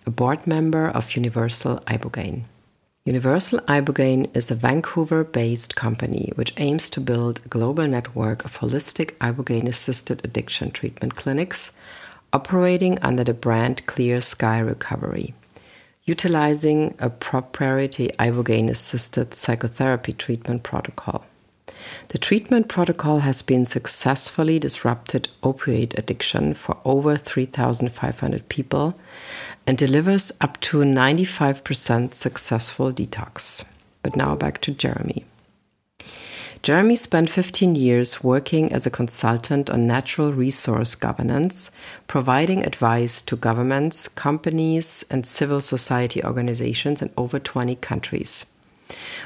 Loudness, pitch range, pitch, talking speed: -22 LUFS, 120-150 Hz, 130 Hz, 110 wpm